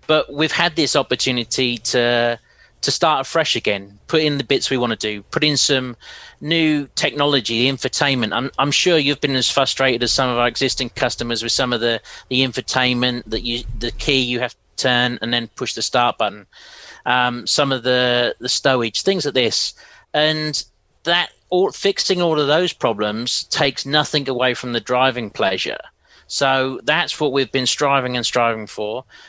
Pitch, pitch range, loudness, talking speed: 130 Hz, 120-145 Hz, -18 LUFS, 185 wpm